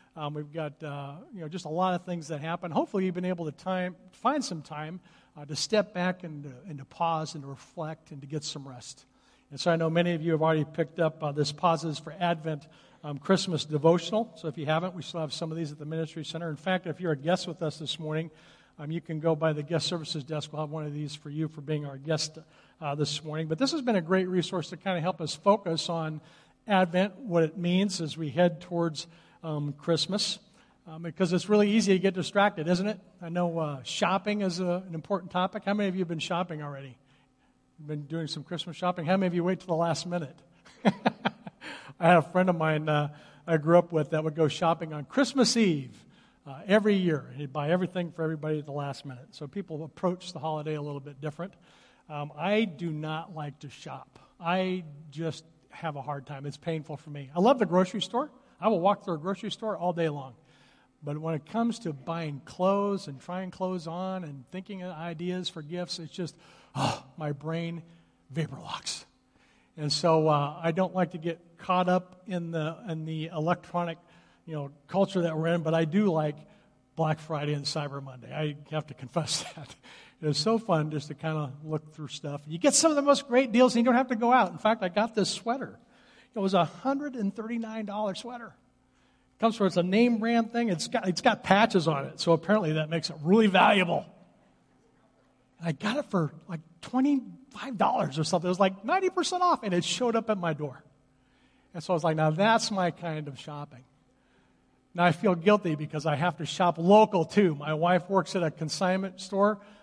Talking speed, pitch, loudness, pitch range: 225 wpm, 170 Hz, -29 LUFS, 155-190 Hz